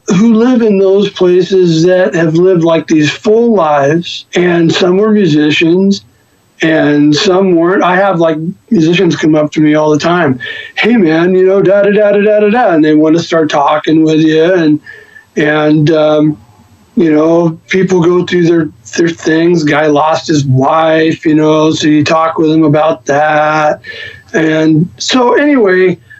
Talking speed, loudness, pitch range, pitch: 170 wpm, -9 LUFS, 155-185 Hz, 165 Hz